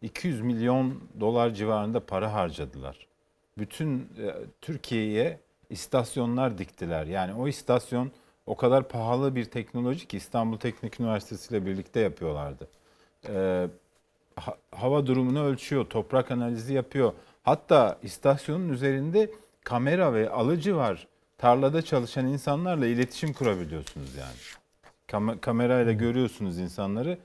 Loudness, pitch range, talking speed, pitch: -28 LUFS, 105-140 Hz, 110 wpm, 120 Hz